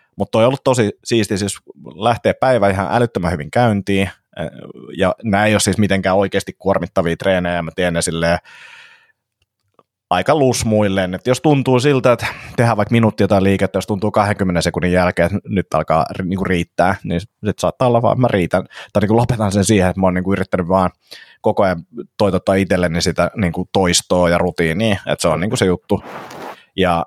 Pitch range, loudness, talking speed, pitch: 90-110 Hz, -16 LUFS, 180 wpm, 100 Hz